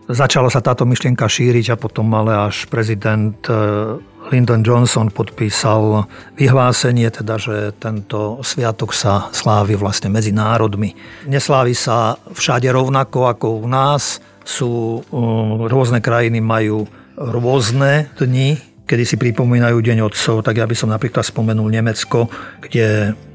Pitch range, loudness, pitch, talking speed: 110-125 Hz, -16 LUFS, 115 Hz, 130 wpm